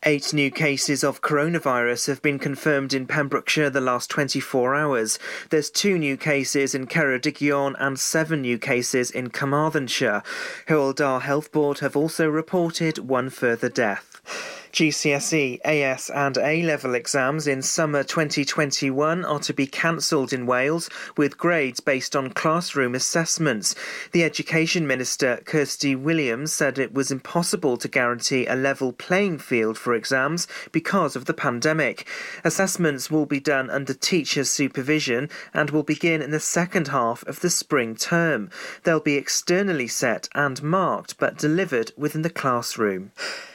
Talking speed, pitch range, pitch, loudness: 145 wpm, 135-160 Hz, 145 Hz, -23 LUFS